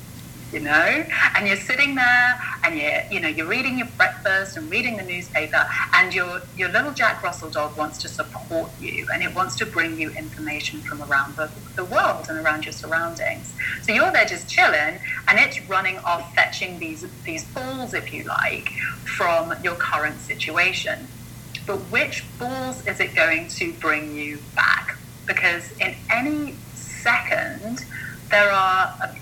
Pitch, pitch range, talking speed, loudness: 165 Hz, 150-205 Hz, 170 wpm, -21 LUFS